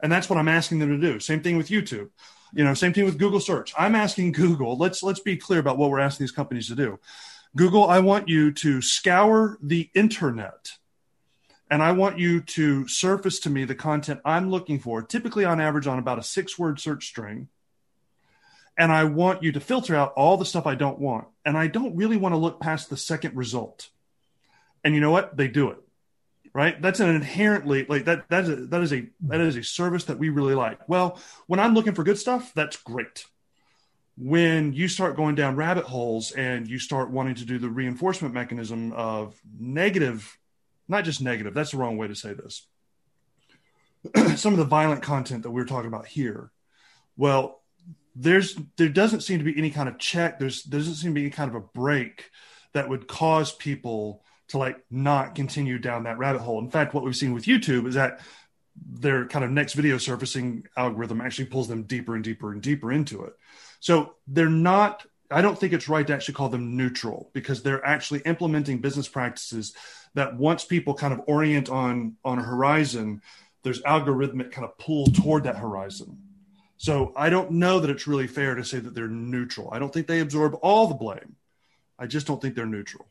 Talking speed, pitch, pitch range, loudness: 205 wpm, 145 Hz, 130-170 Hz, -24 LUFS